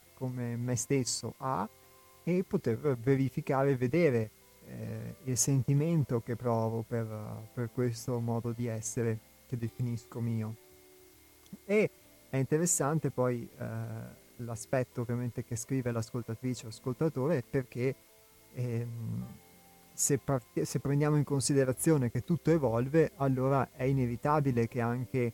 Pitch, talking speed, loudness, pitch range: 125 Hz, 120 wpm, -32 LUFS, 115-135 Hz